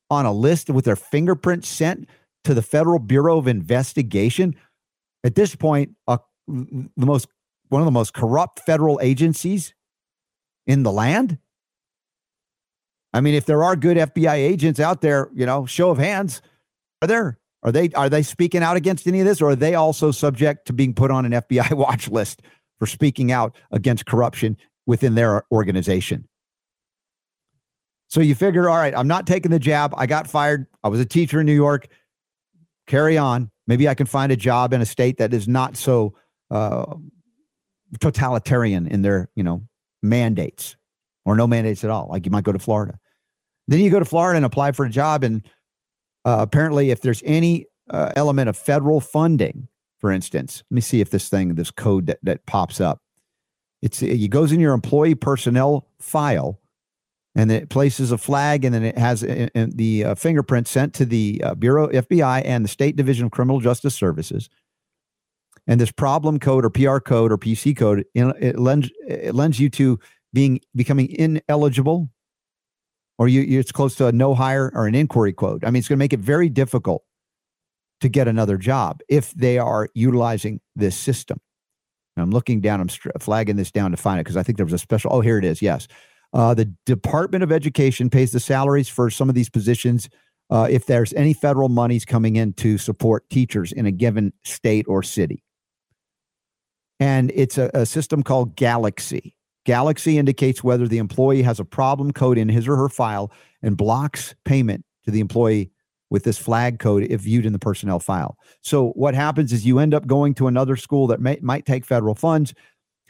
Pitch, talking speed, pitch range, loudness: 130 Hz, 190 wpm, 115-145 Hz, -19 LUFS